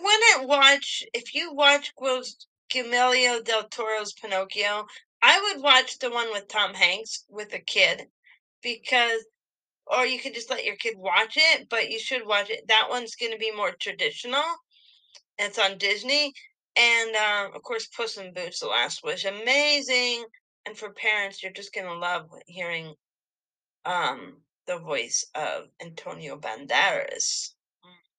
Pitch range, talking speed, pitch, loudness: 210-295 Hz, 150 wpm, 245 Hz, -23 LUFS